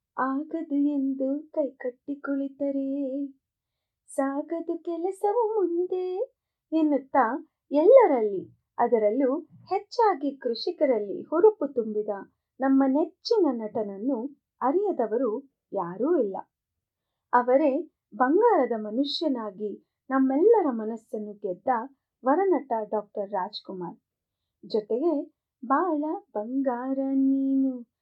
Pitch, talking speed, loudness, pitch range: 275 Hz, 70 wpm, -26 LUFS, 245-330 Hz